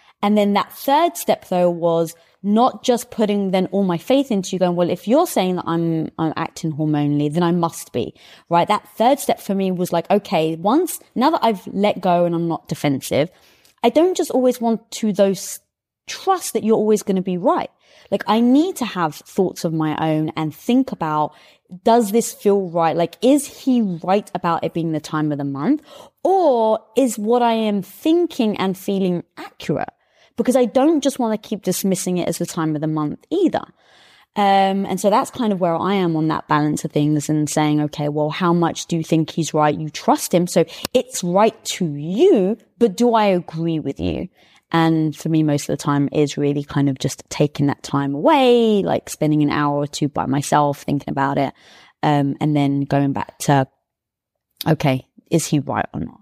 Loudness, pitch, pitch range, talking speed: -19 LUFS, 180 Hz, 155-225 Hz, 210 wpm